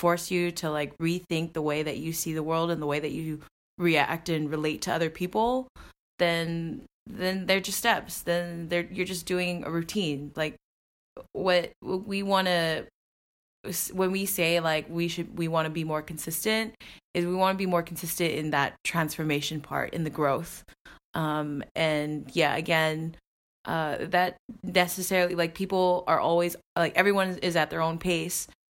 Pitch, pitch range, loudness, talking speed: 170 Hz, 160-180 Hz, -28 LUFS, 175 wpm